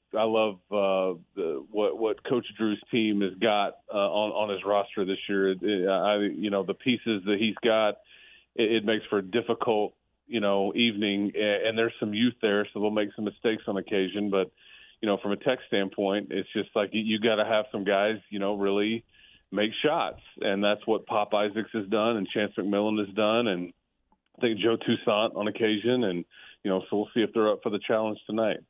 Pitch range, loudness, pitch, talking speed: 100-110 Hz, -27 LUFS, 105 Hz, 215 wpm